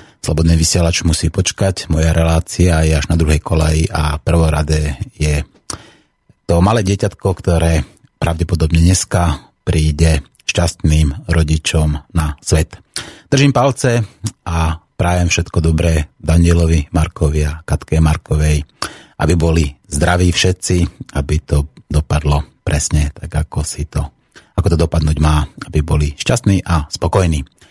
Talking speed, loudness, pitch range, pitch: 125 wpm, -15 LUFS, 75-90 Hz, 80 Hz